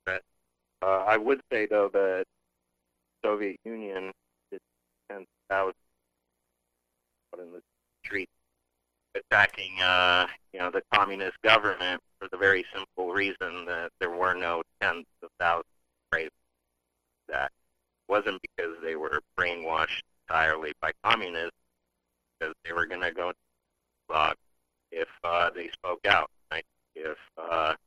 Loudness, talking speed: -28 LUFS, 130 wpm